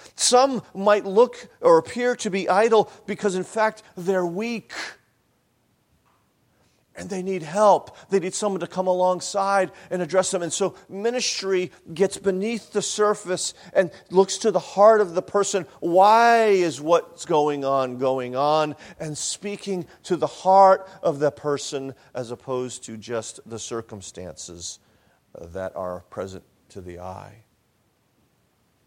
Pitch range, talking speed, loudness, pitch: 135-200 Hz, 140 wpm, -22 LUFS, 185 Hz